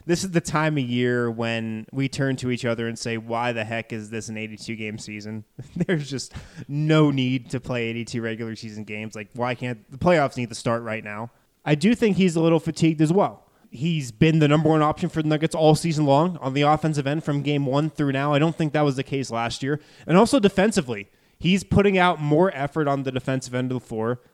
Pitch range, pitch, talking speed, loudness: 115-155 Hz, 135 Hz, 240 wpm, -23 LUFS